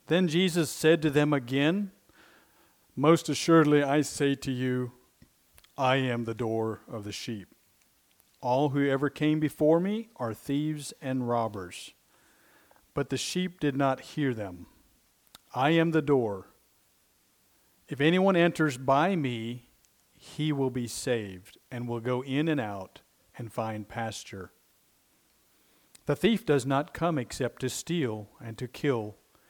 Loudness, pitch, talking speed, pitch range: -28 LUFS, 135 Hz, 140 wpm, 120-155 Hz